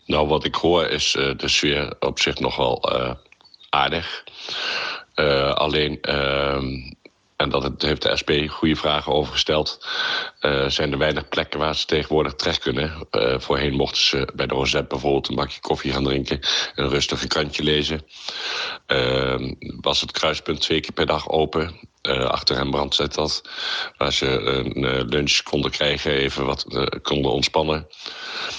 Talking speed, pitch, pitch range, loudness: 170 wpm, 70 Hz, 70-75 Hz, -21 LUFS